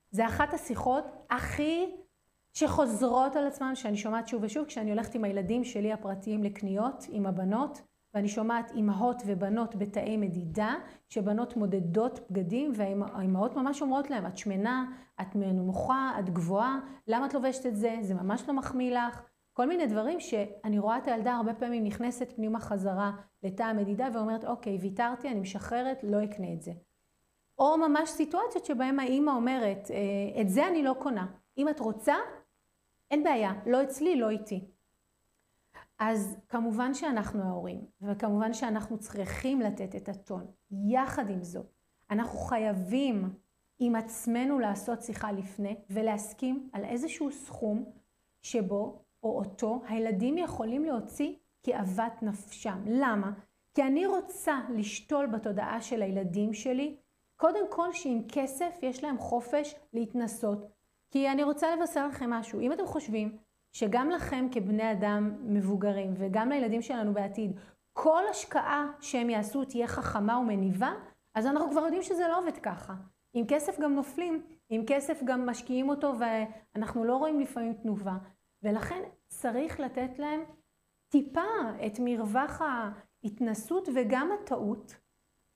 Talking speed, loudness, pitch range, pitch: 140 wpm, -32 LUFS, 210-275 Hz, 235 Hz